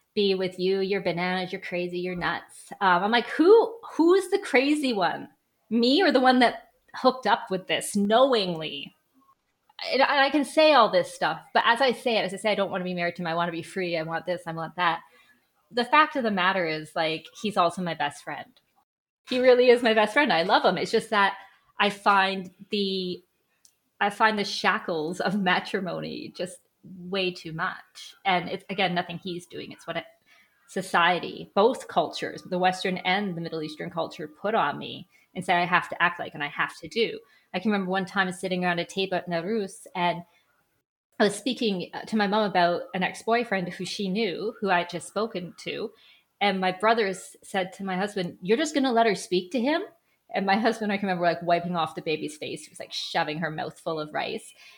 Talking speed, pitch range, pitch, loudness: 215 wpm, 175-225 Hz, 190 Hz, -25 LUFS